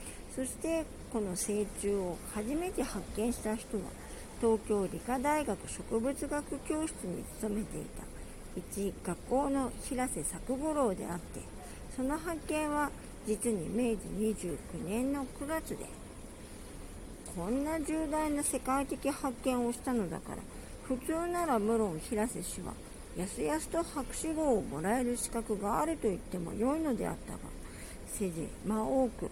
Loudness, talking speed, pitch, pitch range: -35 LUFS, 260 characters per minute, 250 Hz, 215-295 Hz